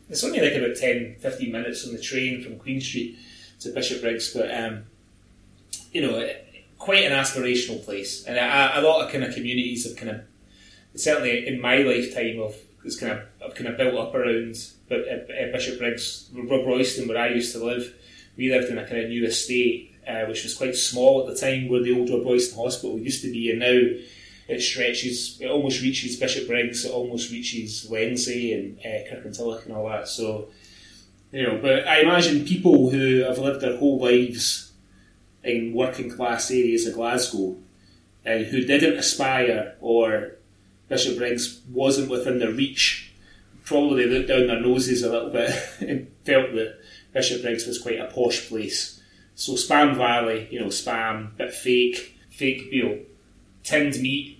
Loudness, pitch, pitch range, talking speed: -23 LUFS, 120 Hz, 115-130 Hz, 180 wpm